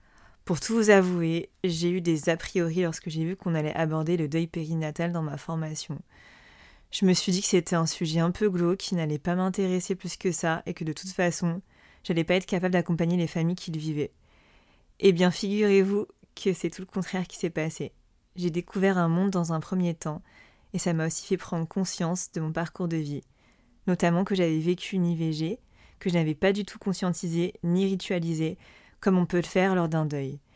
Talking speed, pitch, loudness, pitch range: 215 wpm, 175 Hz, -27 LUFS, 165-185 Hz